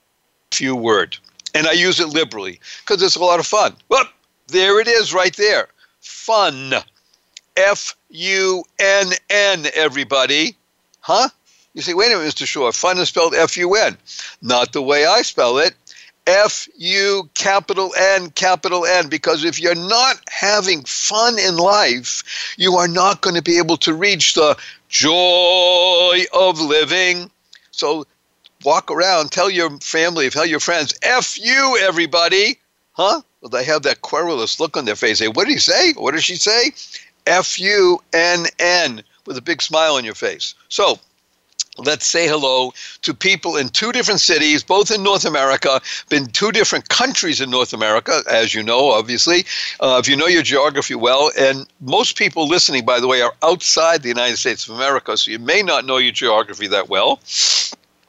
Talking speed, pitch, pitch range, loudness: 175 wpm, 175 Hz, 150-195 Hz, -15 LUFS